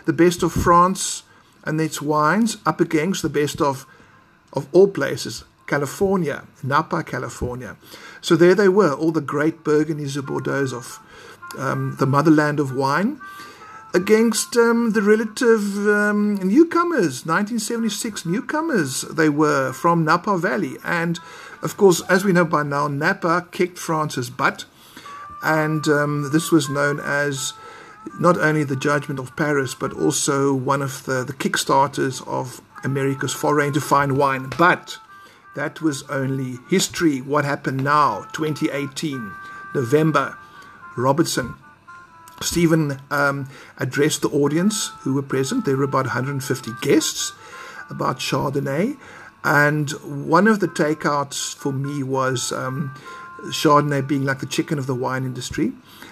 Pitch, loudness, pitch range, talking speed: 155 Hz, -20 LUFS, 140-185 Hz, 135 wpm